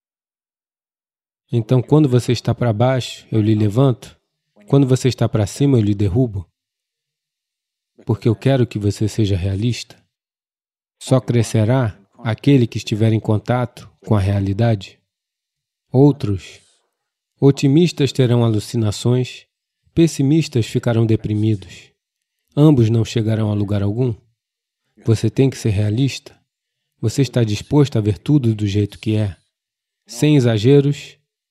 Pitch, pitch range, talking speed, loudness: 115 Hz, 110-135 Hz, 120 wpm, -17 LUFS